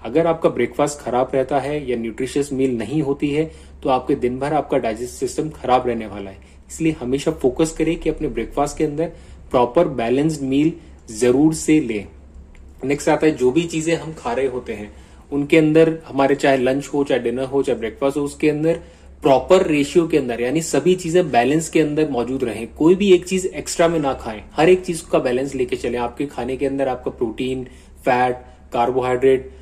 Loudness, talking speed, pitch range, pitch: -19 LUFS, 200 wpm, 125-160 Hz, 140 Hz